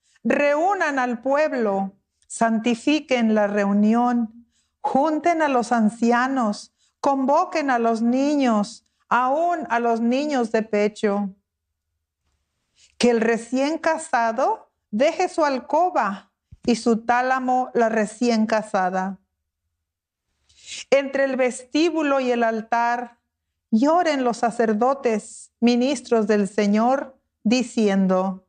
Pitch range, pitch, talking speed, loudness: 210-270 Hz, 235 Hz, 95 wpm, -21 LUFS